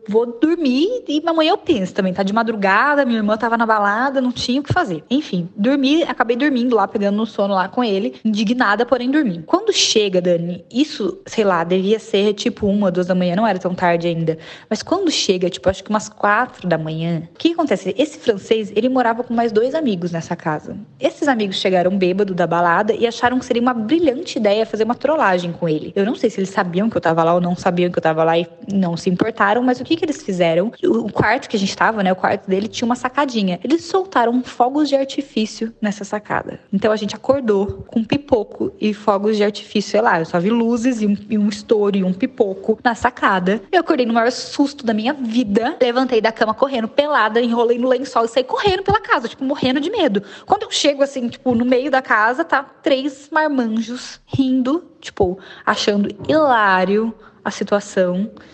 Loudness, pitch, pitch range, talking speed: -18 LUFS, 225 Hz, 195-265 Hz, 215 wpm